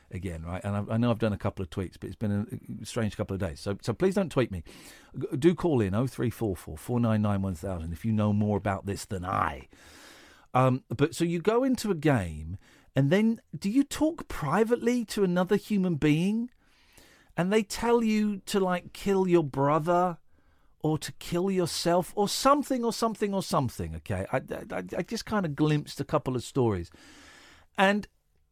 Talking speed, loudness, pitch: 185 wpm, -28 LUFS, 145 Hz